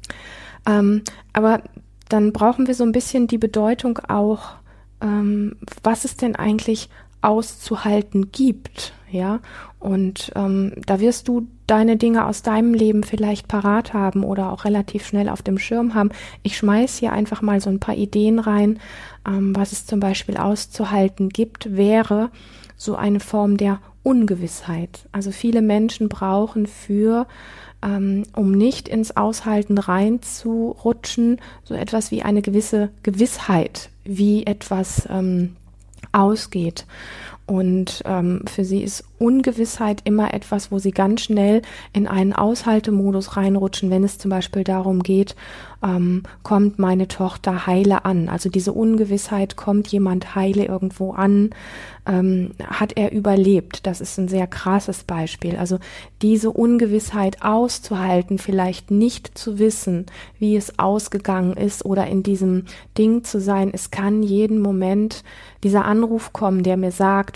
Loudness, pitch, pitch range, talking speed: -20 LUFS, 205 Hz, 195-220 Hz, 140 wpm